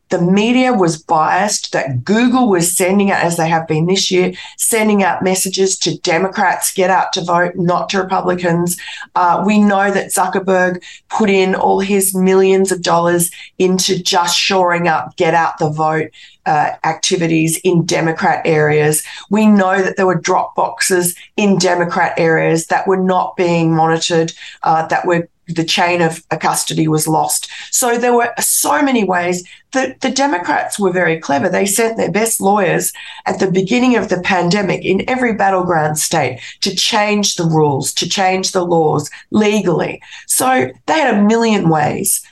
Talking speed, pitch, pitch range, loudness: 170 wpm, 180 Hz, 165-195 Hz, -14 LUFS